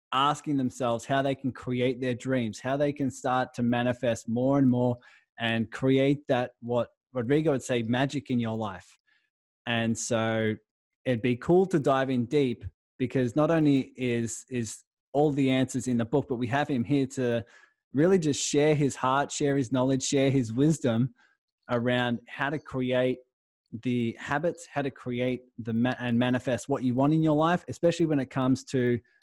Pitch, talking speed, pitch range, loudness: 130 Hz, 185 wpm, 120-140 Hz, -27 LUFS